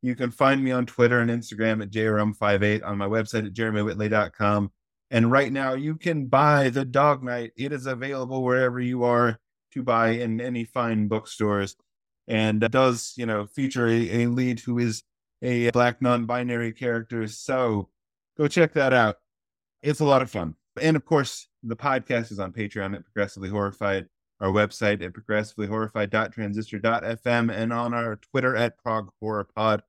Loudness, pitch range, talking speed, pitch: -25 LUFS, 105-125 Hz, 165 wpm, 115 Hz